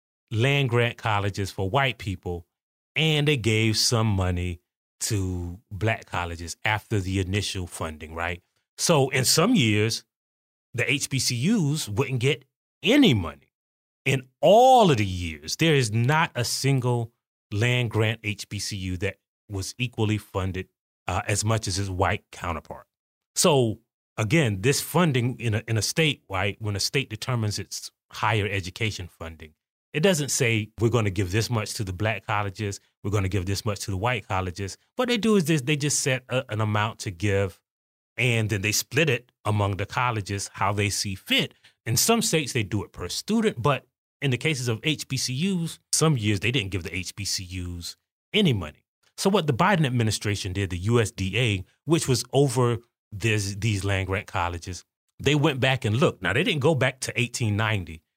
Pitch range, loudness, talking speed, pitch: 100-130 Hz, -25 LUFS, 175 wpm, 110 Hz